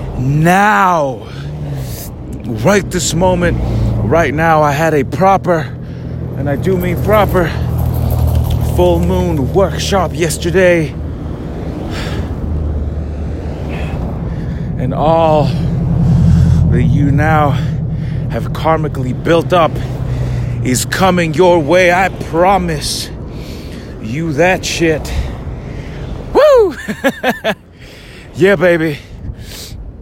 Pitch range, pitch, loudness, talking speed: 125-170 Hz, 150 Hz, -13 LUFS, 80 wpm